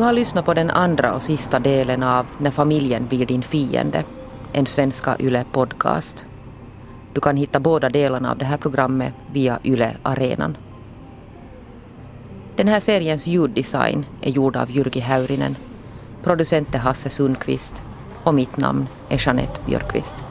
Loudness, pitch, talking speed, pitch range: -20 LUFS, 135 Hz, 140 wpm, 125-145 Hz